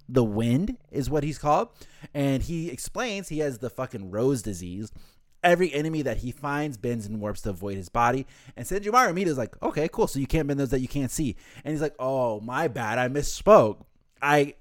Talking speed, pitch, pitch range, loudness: 210 wpm, 135 Hz, 120-155 Hz, -26 LUFS